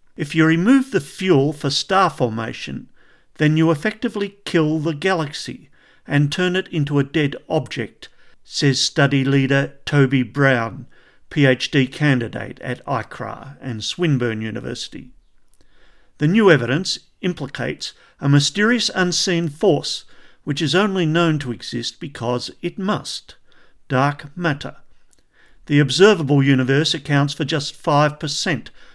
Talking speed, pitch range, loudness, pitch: 120 wpm, 135-165 Hz, -19 LUFS, 145 Hz